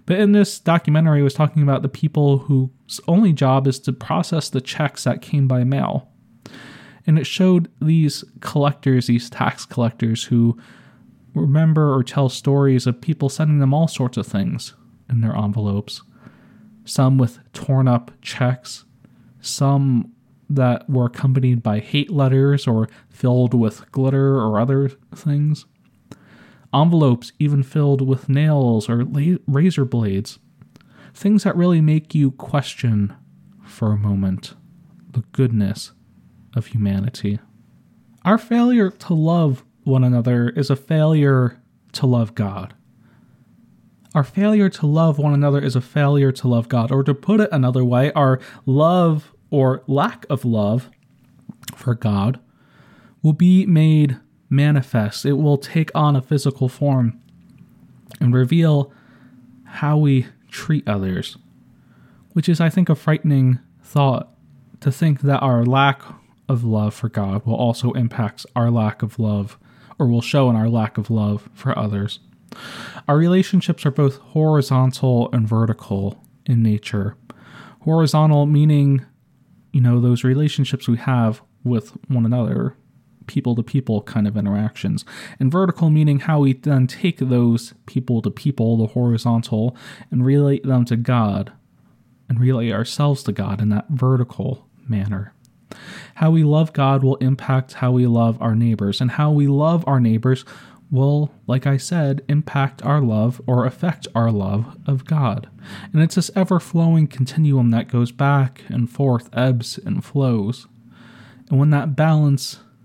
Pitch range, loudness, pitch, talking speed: 120-150 Hz, -19 LUFS, 130 Hz, 145 wpm